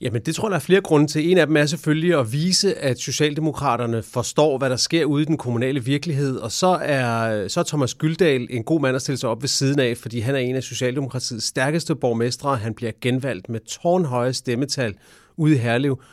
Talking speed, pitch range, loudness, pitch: 225 wpm, 120-155 Hz, -21 LUFS, 135 Hz